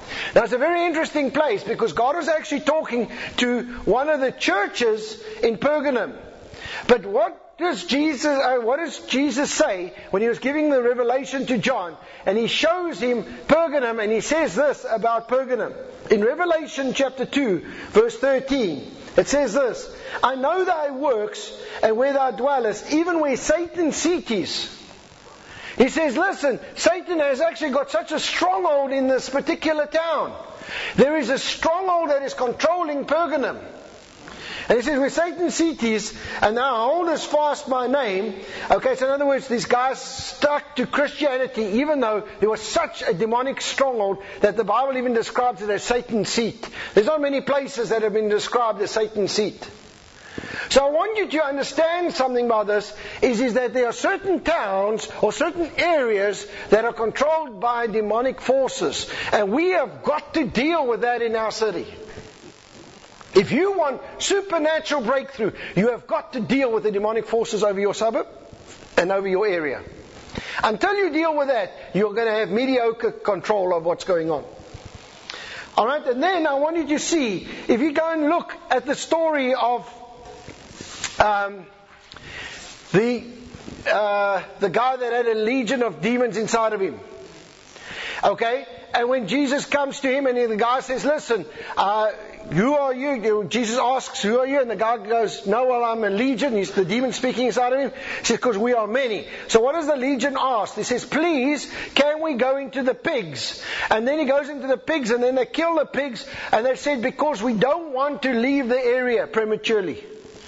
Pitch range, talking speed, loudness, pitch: 230-300 Hz, 180 wpm, -22 LUFS, 260 Hz